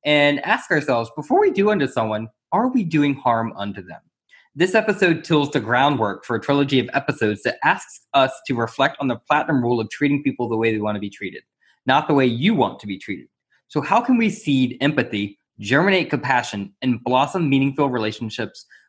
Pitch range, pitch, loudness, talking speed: 115-150 Hz, 135 Hz, -20 LUFS, 200 wpm